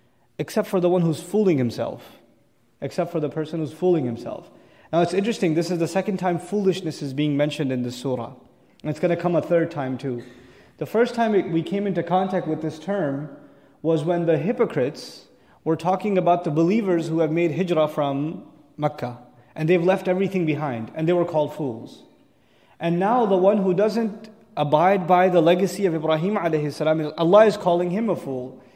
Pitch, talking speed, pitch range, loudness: 165 Hz, 190 wpm, 150-185 Hz, -22 LUFS